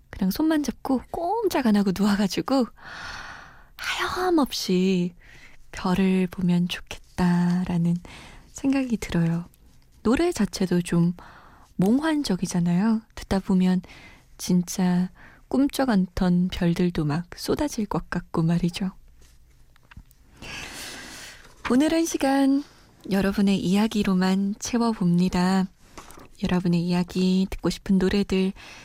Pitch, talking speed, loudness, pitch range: 190 Hz, 215 characters per minute, -24 LUFS, 180-230 Hz